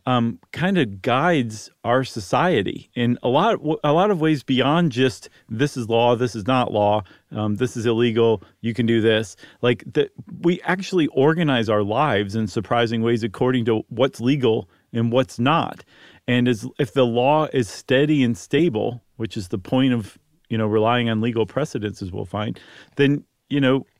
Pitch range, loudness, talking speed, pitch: 110-135 Hz, -21 LUFS, 185 wpm, 120 Hz